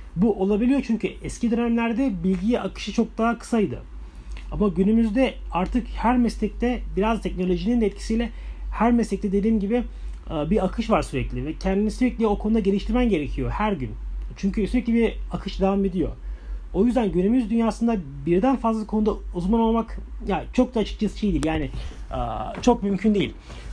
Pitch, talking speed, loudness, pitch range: 210 Hz, 155 wpm, -24 LUFS, 180-230 Hz